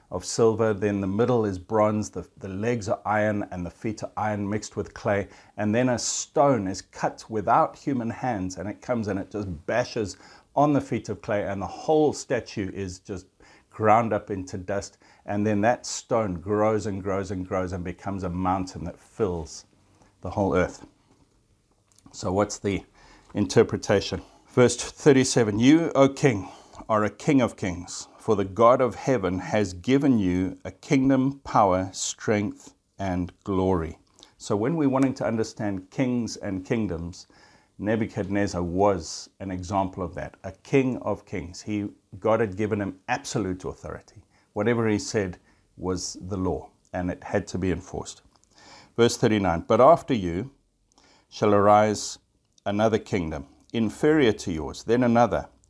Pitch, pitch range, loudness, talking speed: 105 Hz, 95-115 Hz, -25 LUFS, 160 wpm